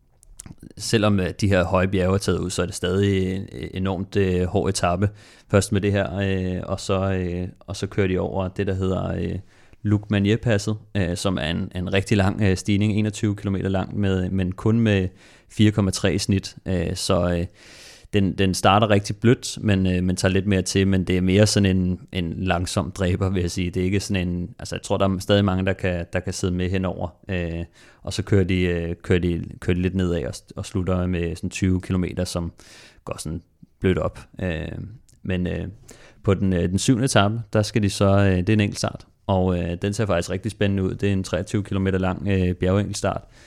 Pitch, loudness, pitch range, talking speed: 95 Hz, -23 LUFS, 90-100 Hz, 215 wpm